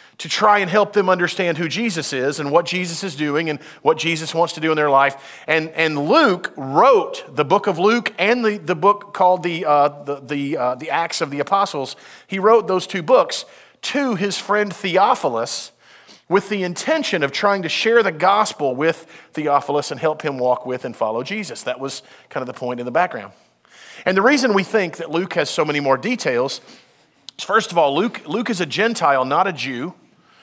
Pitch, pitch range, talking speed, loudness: 170 Hz, 150-205 Hz, 210 wpm, -19 LUFS